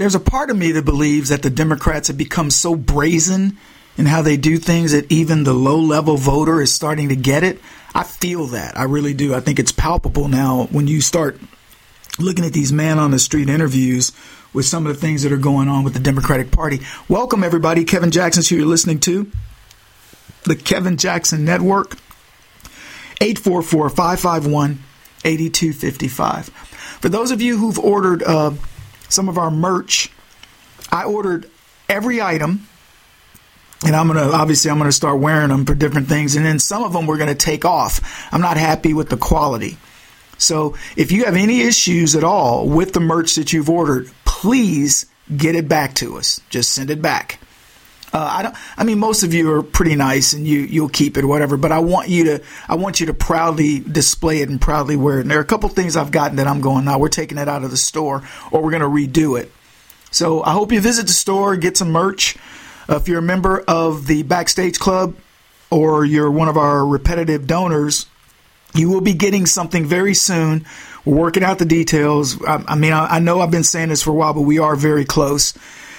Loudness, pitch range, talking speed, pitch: -16 LUFS, 145-175 Hz, 205 wpm, 155 Hz